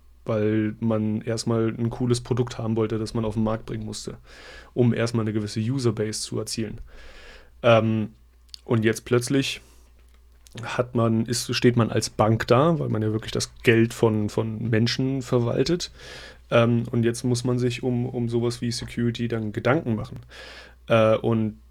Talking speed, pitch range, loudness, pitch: 165 wpm, 110-120 Hz, -24 LUFS, 115 Hz